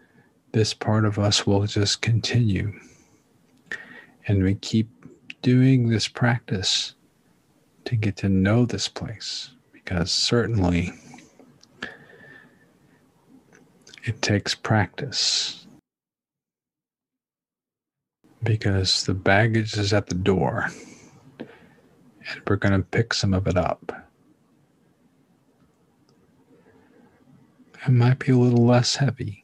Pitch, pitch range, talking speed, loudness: 110 Hz, 100-120 Hz, 95 wpm, -22 LUFS